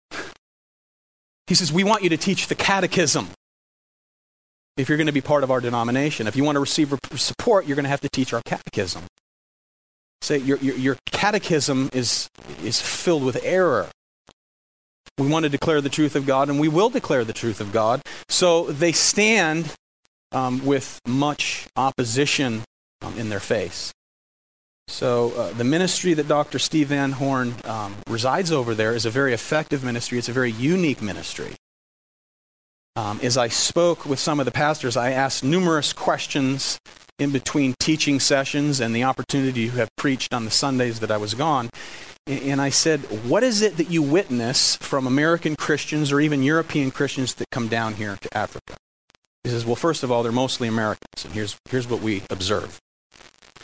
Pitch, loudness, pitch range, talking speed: 135 Hz, -22 LUFS, 120-150 Hz, 180 wpm